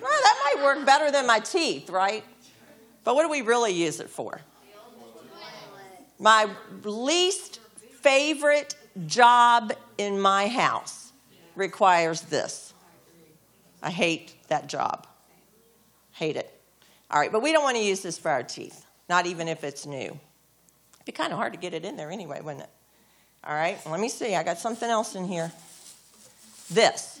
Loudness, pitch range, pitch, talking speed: -24 LUFS, 180-275 Hz, 220 Hz, 165 wpm